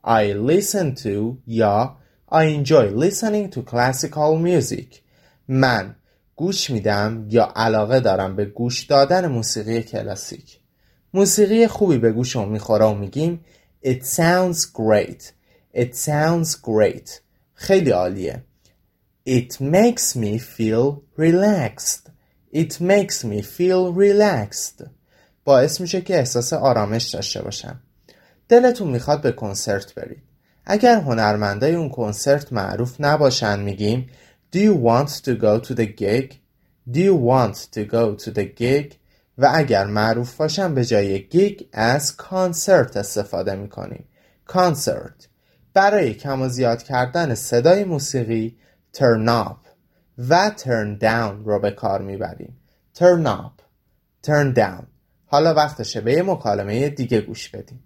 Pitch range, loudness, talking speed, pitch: 110-165 Hz, -19 LUFS, 125 wpm, 125 Hz